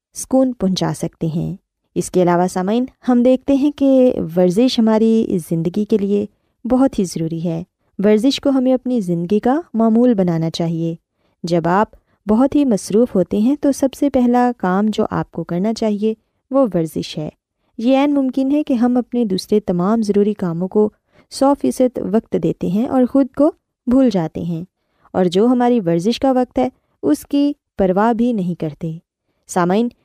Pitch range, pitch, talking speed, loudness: 180-255 Hz, 220 Hz, 175 wpm, -17 LUFS